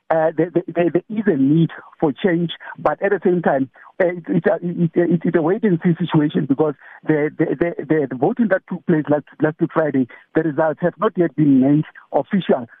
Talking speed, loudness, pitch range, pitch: 210 wpm, -19 LUFS, 155-180 Hz, 165 Hz